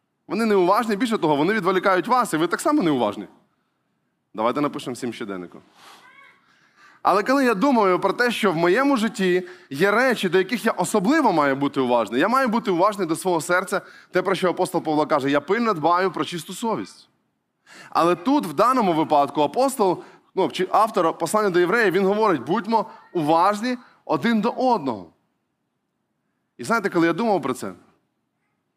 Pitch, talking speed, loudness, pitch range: 190 Hz, 165 wpm, -21 LUFS, 170-230 Hz